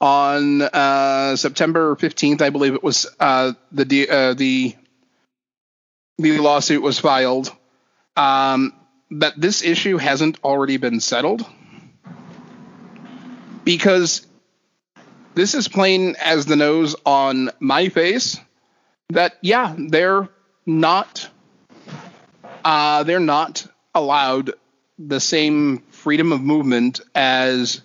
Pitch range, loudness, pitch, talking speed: 135-170 Hz, -17 LUFS, 150 Hz, 105 wpm